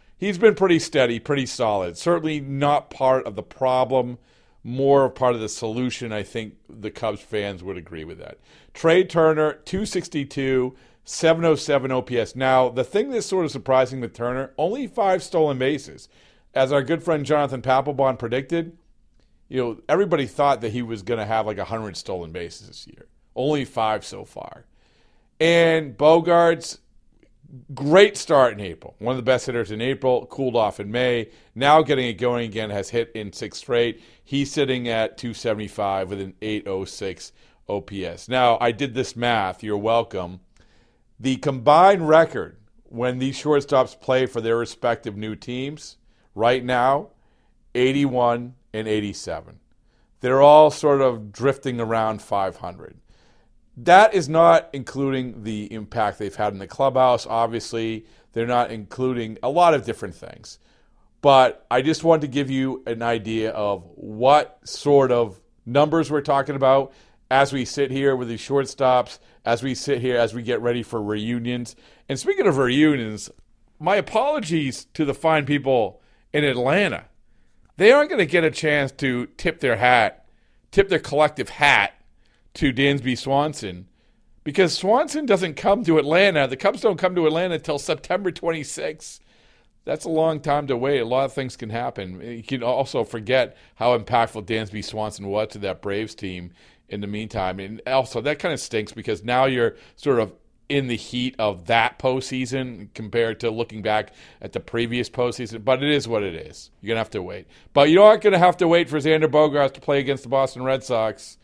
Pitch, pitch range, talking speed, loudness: 130 Hz, 115-145 Hz, 170 wpm, -21 LUFS